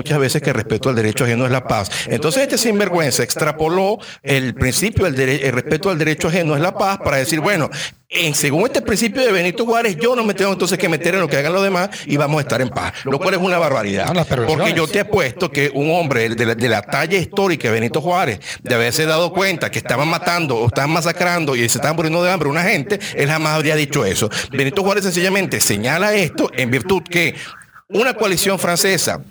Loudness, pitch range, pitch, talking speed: -17 LUFS, 135-190 Hz, 160 Hz, 230 wpm